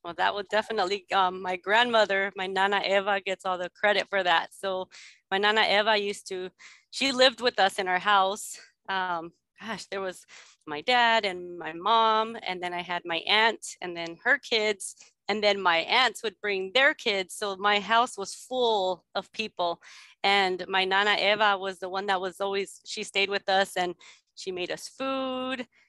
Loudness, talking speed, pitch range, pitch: -26 LUFS, 190 wpm, 185-220 Hz, 195 Hz